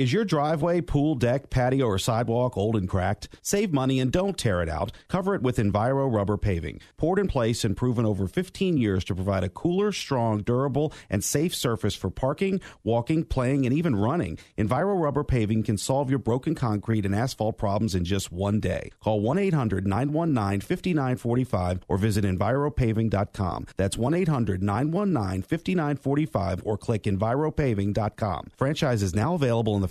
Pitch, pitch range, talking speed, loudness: 120 Hz, 100-145 Hz, 170 wpm, -26 LUFS